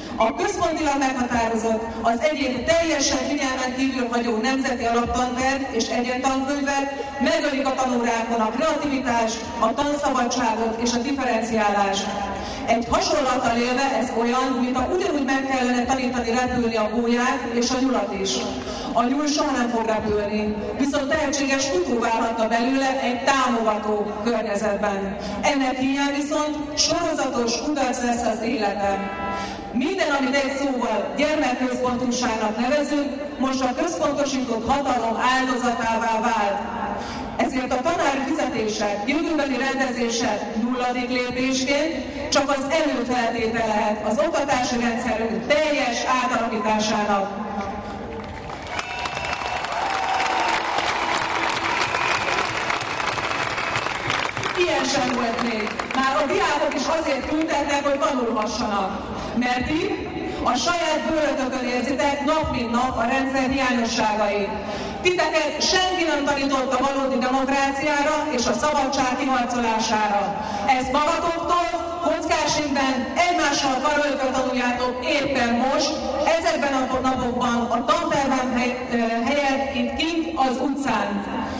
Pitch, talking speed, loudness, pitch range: 255 Hz, 105 wpm, -22 LUFS, 230-285 Hz